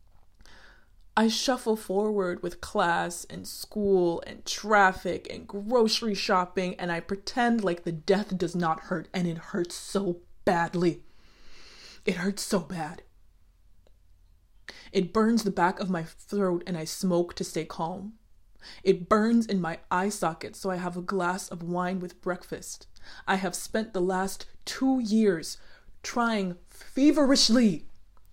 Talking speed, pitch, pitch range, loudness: 140 wpm, 185 Hz, 170-205 Hz, -28 LUFS